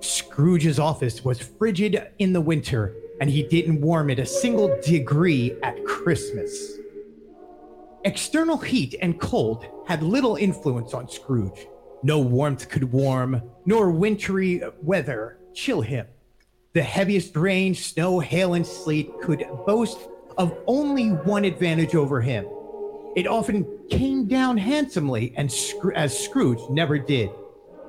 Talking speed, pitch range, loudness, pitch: 130 wpm, 140-215 Hz, -23 LUFS, 175 Hz